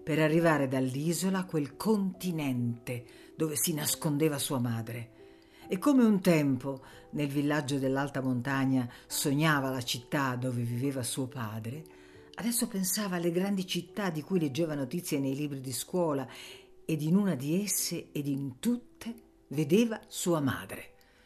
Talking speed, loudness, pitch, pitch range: 140 wpm, -31 LUFS, 150 Hz, 130-175 Hz